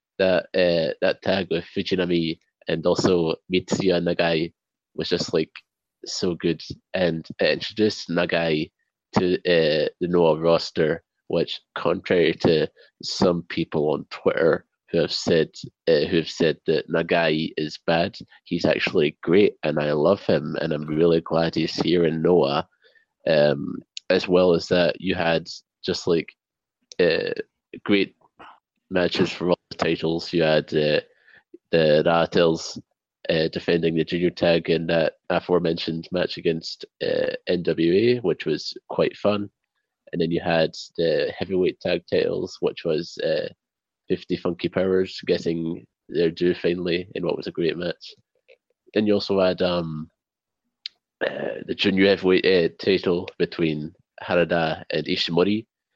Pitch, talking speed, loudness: 90 Hz, 140 wpm, -23 LUFS